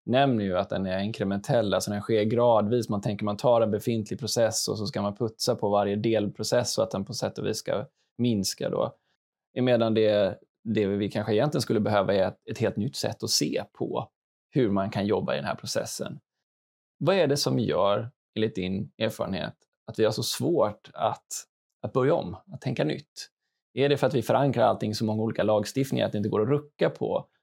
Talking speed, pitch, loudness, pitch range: 210 wpm, 110 Hz, -27 LUFS, 100-120 Hz